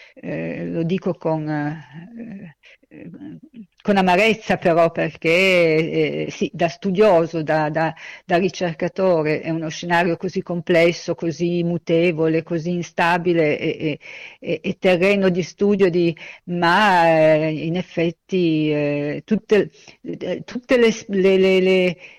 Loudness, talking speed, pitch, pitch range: -19 LUFS, 125 wpm, 175 Hz, 160-190 Hz